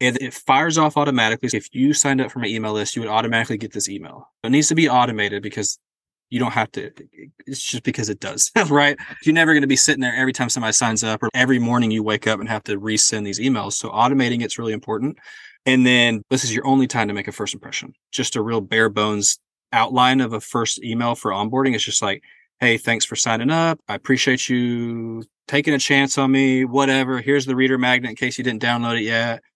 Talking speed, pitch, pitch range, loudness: 235 wpm, 120 Hz, 110-135 Hz, -19 LUFS